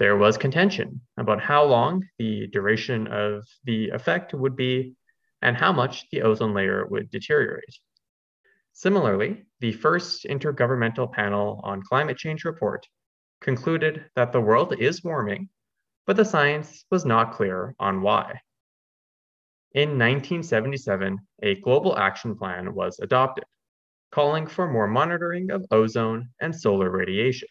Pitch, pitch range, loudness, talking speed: 135 Hz, 110-175 Hz, -24 LUFS, 135 wpm